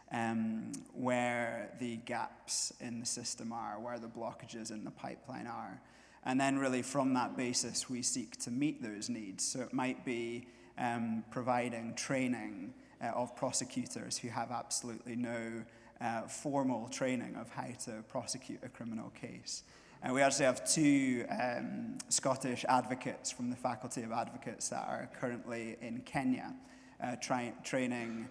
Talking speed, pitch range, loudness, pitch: 155 wpm, 115-135 Hz, -37 LUFS, 125 Hz